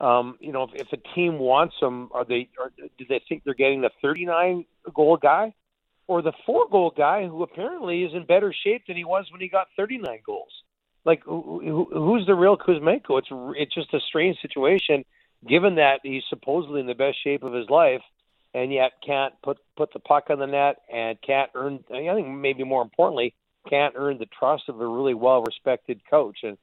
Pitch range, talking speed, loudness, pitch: 135-175 Hz, 215 wpm, -23 LUFS, 145 Hz